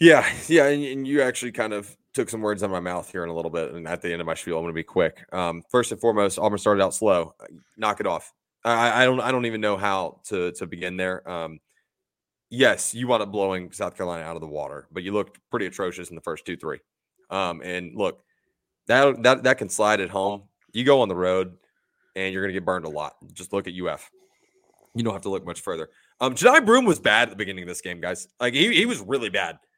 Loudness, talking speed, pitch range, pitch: -24 LUFS, 260 wpm, 90-130 Hz, 100 Hz